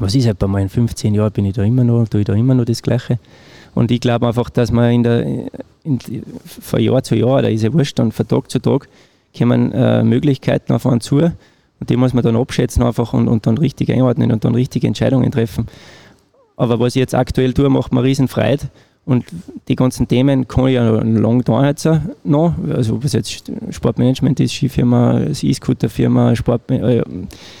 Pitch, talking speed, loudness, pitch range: 120 Hz, 210 wpm, -16 LUFS, 115-130 Hz